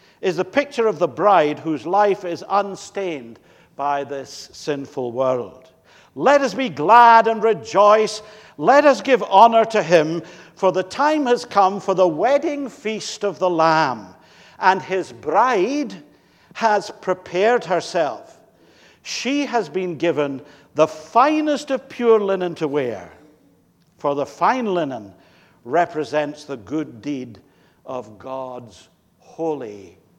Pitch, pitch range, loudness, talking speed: 185 Hz, 150-220 Hz, -19 LUFS, 130 wpm